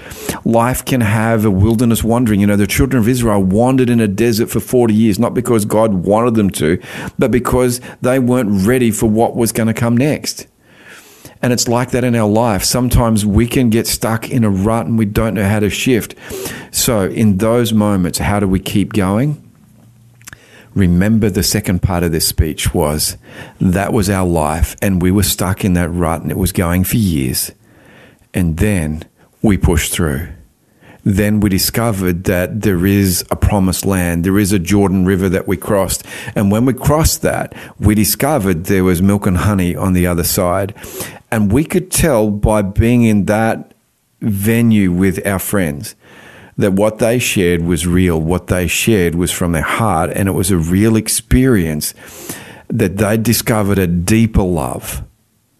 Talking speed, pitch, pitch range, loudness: 180 wpm, 105 Hz, 95-115 Hz, -14 LUFS